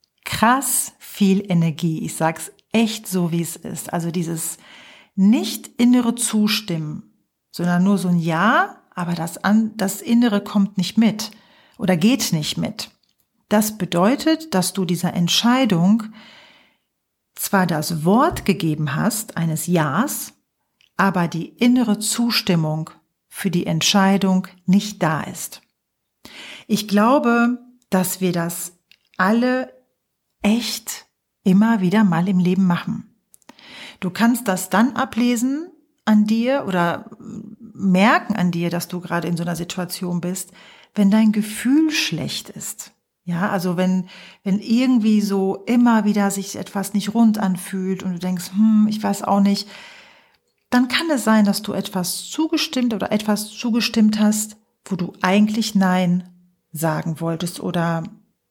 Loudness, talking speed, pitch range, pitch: -19 LUFS, 135 wpm, 180-225 Hz, 200 Hz